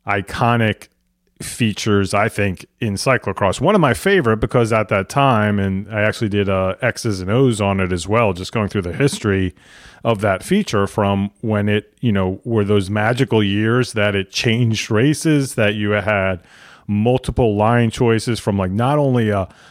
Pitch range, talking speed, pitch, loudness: 100-120 Hz, 175 wpm, 105 Hz, -18 LUFS